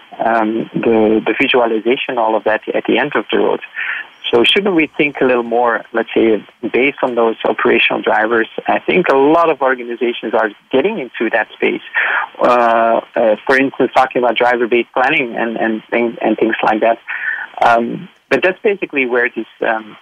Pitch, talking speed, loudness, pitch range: 120 Hz, 190 wpm, -14 LUFS, 115-135 Hz